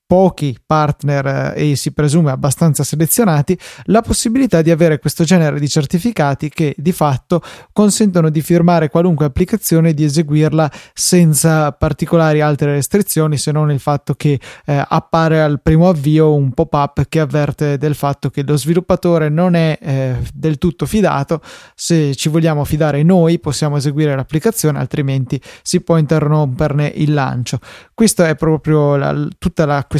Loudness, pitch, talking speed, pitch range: -14 LUFS, 155 Hz, 155 wpm, 145-170 Hz